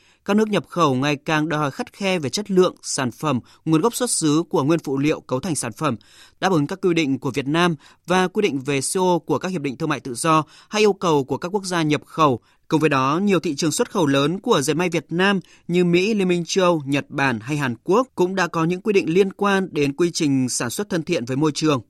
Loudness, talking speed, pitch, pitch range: -21 LUFS, 270 wpm, 160 Hz, 145-185 Hz